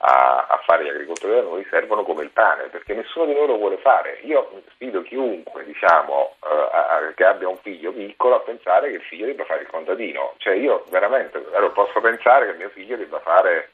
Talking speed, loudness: 210 wpm, -20 LUFS